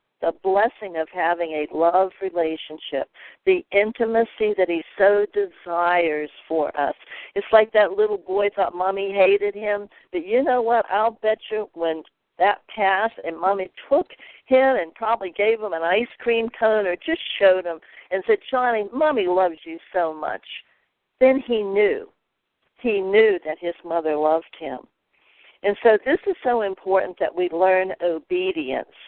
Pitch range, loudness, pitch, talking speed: 175-230 Hz, -22 LUFS, 200 Hz, 160 wpm